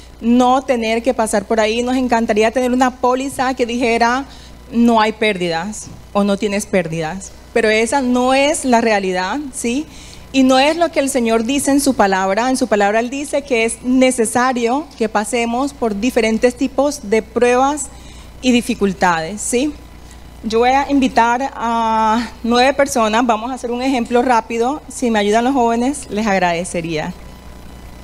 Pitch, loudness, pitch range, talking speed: 235 Hz, -16 LUFS, 215-260 Hz, 165 wpm